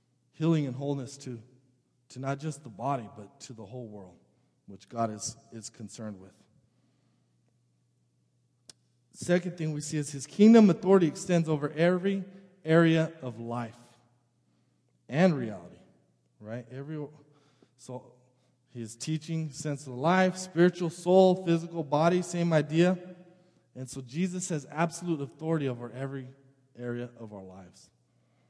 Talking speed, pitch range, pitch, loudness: 130 wpm, 115-165 Hz, 135 Hz, -28 LUFS